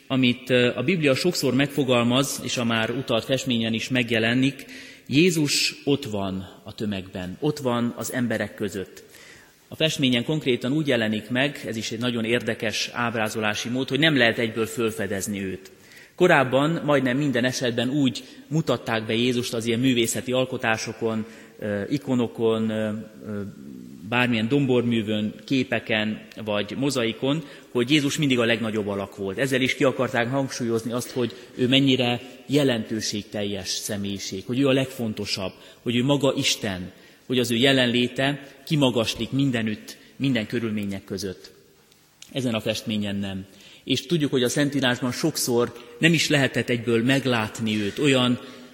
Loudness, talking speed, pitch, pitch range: -23 LUFS, 135 wpm, 120 Hz, 110-135 Hz